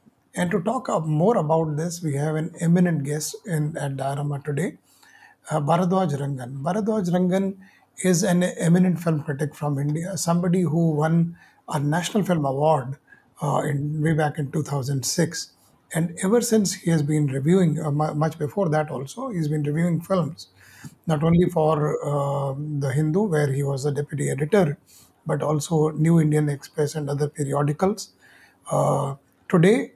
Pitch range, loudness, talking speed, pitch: 145-180 Hz, -23 LUFS, 155 wpm, 155 Hz